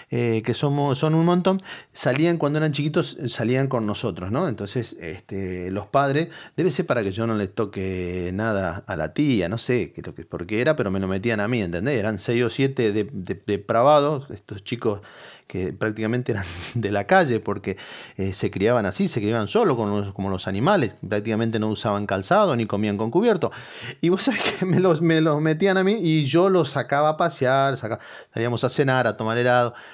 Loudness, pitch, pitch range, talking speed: -23 LUFS, 120 Hz, 105-150 Hz, 210 wpm